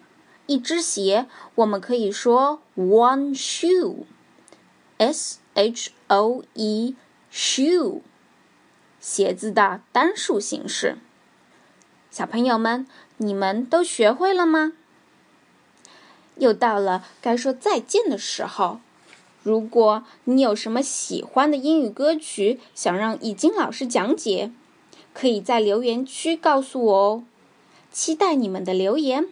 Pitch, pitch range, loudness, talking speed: 245 Hz, 215-310 Hz, -22 LUFS, 180 characters per minute